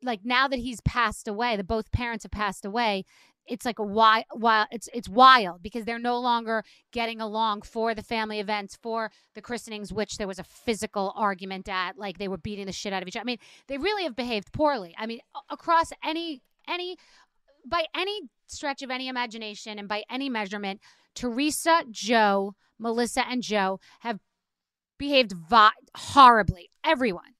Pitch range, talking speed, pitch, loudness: 210-255 Hz, 175 wpm, 230 Hz, -26 LUFS